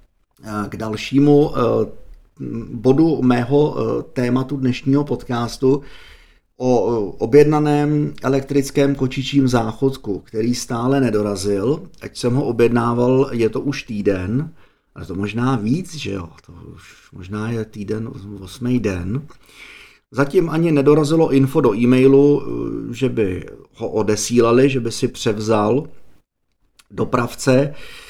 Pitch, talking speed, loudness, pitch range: 125 Hz, 110 wpm, -18 LUFS, 110-140 Hz